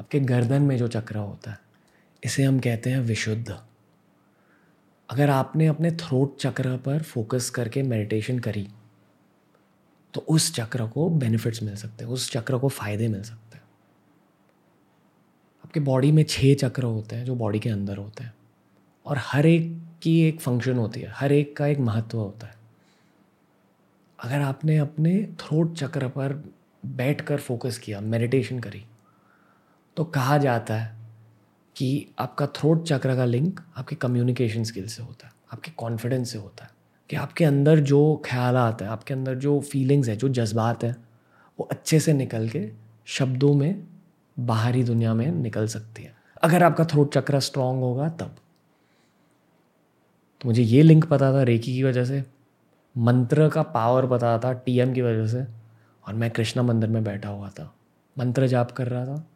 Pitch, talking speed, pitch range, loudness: 125 Hz, 165 wpm, 115-145 Hz, -24 LUFS